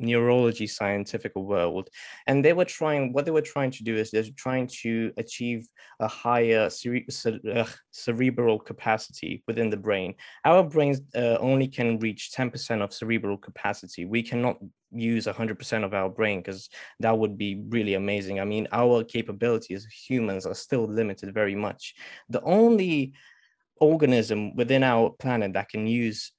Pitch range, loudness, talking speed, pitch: 105-125 Hz, -26 LUFS, 160 wpm, 115 Hz